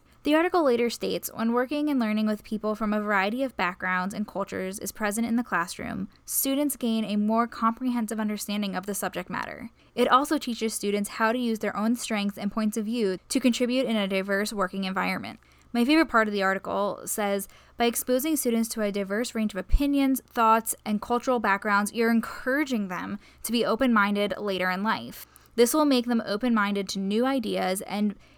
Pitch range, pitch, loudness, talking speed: 200-245 Hz, 220 Hz, -26 LUFS, 195 wpm